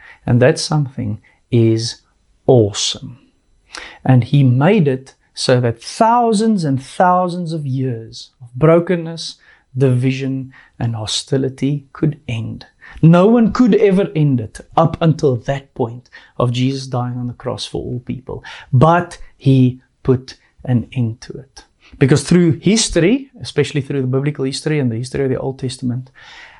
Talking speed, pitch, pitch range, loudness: 145 wpm, 135 Hz, 125-160 Hz, -16 LUFS